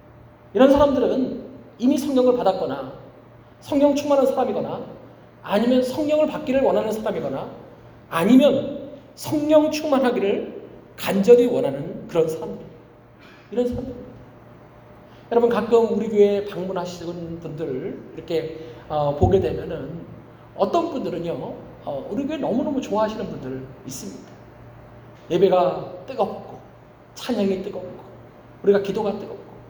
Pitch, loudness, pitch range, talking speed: 220 Hz, -21 LUFS, 180-270 Hz, 285 characters per minute